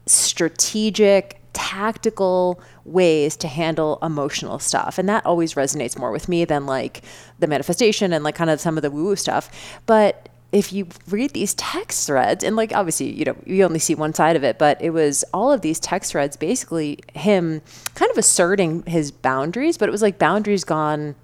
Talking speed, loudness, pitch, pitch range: 190 wpm, -20 LUFS, 170 Hz, 155-200 Hz